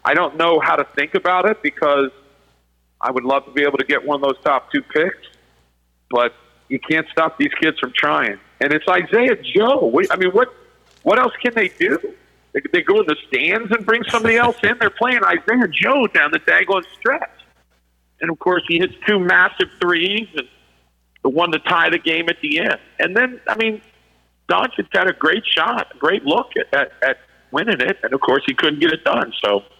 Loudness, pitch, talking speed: -17 LUFS, 175 Hz, 215 wpm